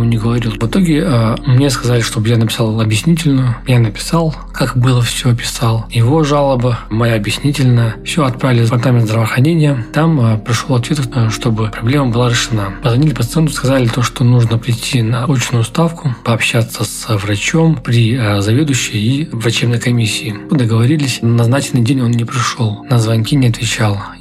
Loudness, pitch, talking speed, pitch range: -13 LUFS, 120 Hz, 155 wpm, 115-135 Hz